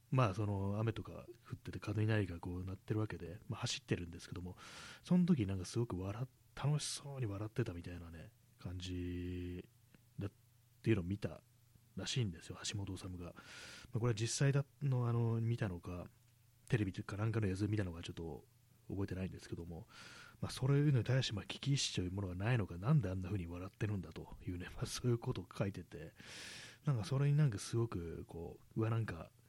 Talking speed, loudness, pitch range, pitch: 400 characters per minute, -40 LUFS, 90-120 Hz, 110 Hz